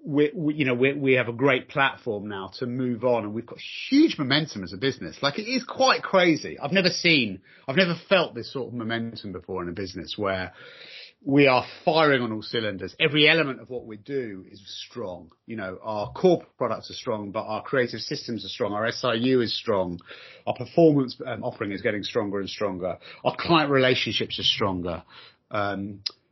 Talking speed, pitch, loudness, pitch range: 205 wpm, 125 Hz, -24 LUFS, 105-145 Hz